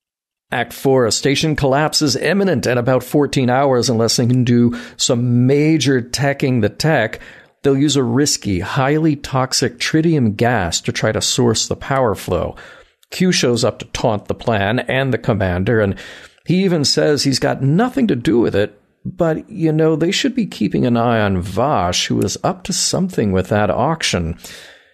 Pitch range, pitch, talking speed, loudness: 115-155 Hz, 130 Hz, 180 wpm, -16 LUFS